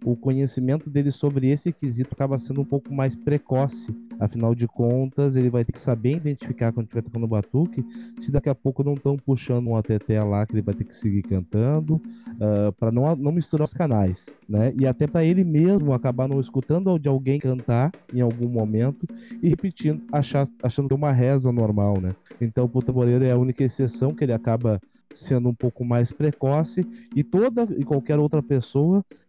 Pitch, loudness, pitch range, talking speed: 135 Hz, -23 LUFS, 120-145 Hz, 195 wpm